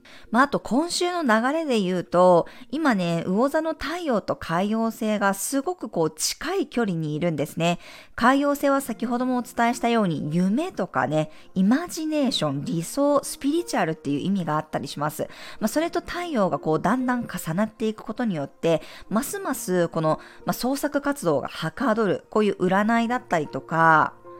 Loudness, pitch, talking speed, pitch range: -24 LUFS, 220 Hz, 360 characters per minute, 175-270 Hz